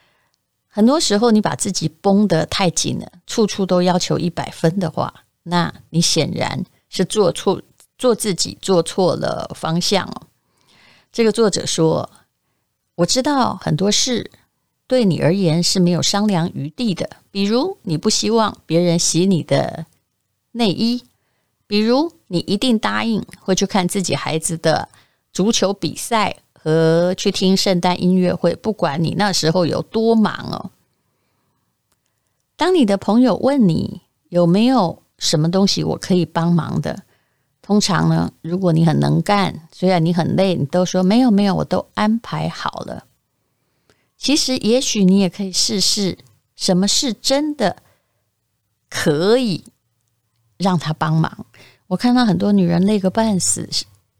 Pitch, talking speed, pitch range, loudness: 185 Hz, 210 characters per minute, 165-210 Hz, -17 LUFS